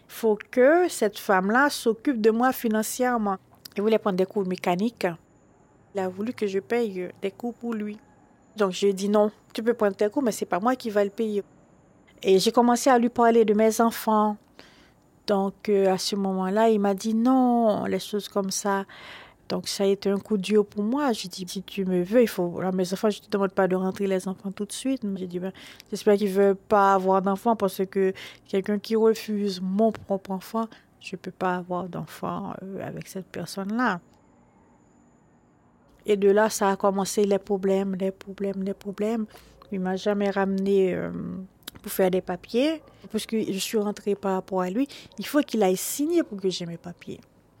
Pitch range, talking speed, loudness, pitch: 190-220 Hz, 205 wpm, -25 LUFS, 200 Hz